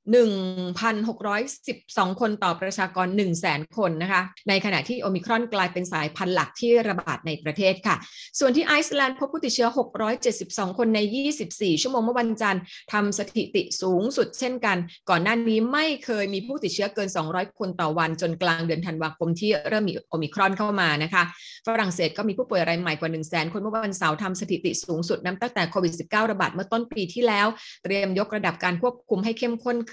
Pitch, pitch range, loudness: 200 Hz, 180-230 Hz, -25 LUFS